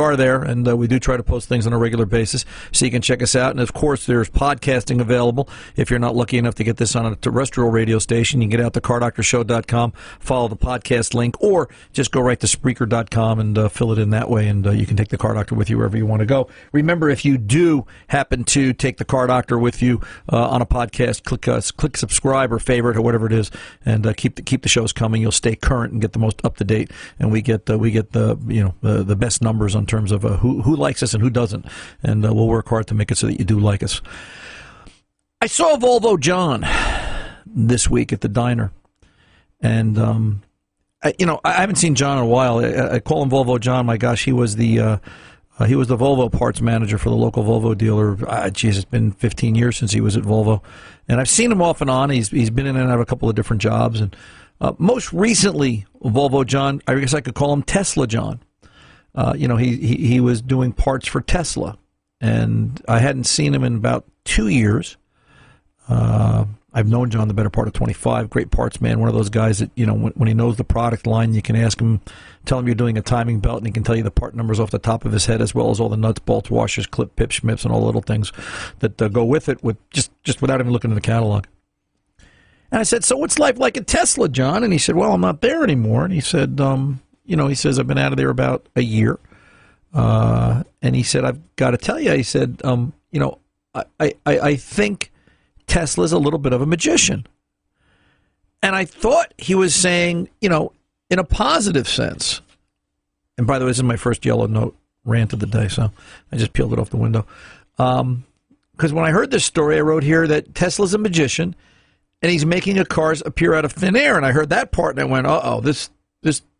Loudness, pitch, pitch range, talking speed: -18 LUFS, 120 Hz, 110-135 Hz, 245 wpm